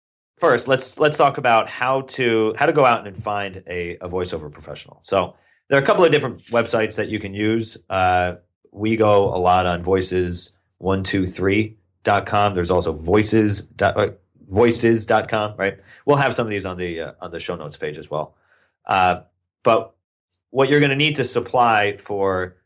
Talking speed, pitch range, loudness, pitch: 175 wpm, 90-115 Hz, -19 LUFS, 105 Hz